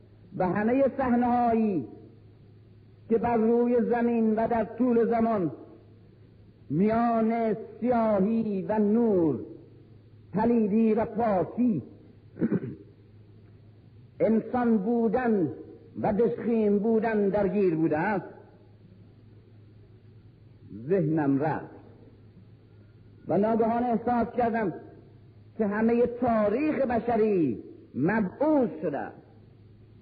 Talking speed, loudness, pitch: 75 wpm, -26 LUFS, 195 Hz